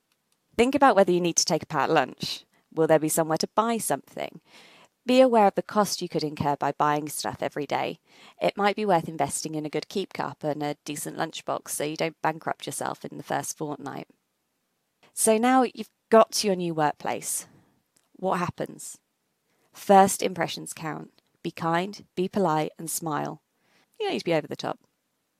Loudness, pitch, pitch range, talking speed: -25 LUFS, 170 Hz, 155-210 Hz, 190 wpm